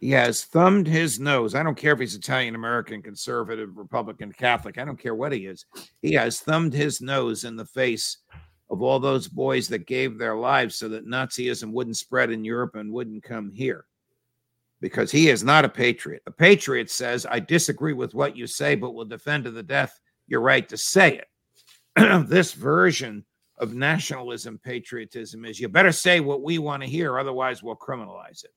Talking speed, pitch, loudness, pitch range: 195 wpm, 125 Hz, -22 LUFS, 115-145 Hz